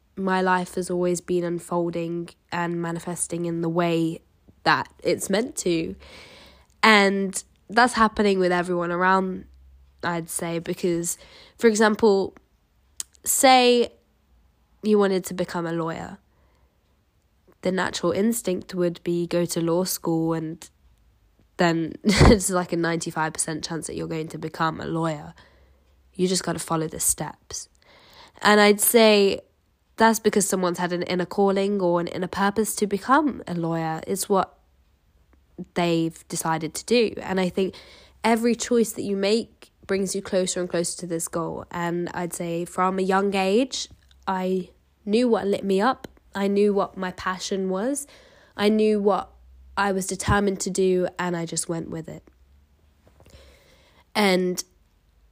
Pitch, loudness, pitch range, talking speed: 180 Hz, -23 LUFS, 165-195 Hz, 150 wpm